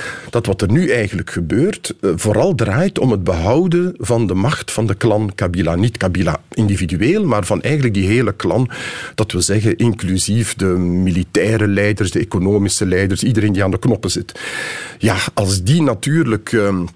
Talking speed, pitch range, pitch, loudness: 170 wpm, 95-115 Hz, 105 Hz, -16 LUFS